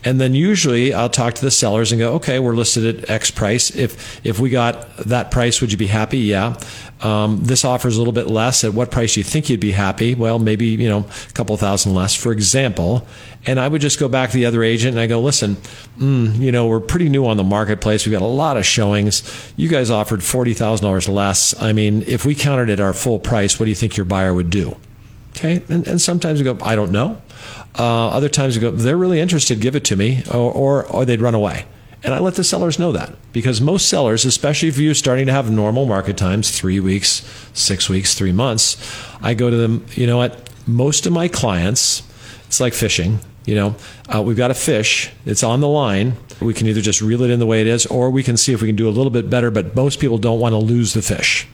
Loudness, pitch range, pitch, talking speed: -16 LUFS, 110-130 Hz, 115 Hz, 250 wpm